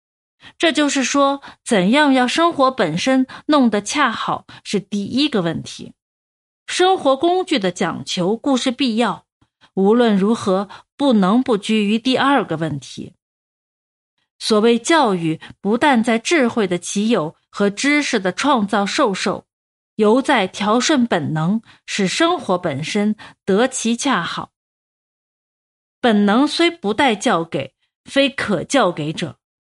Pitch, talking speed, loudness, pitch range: 230 Hz, 190 characters per minute, -17 LUFS, 200-275 Hz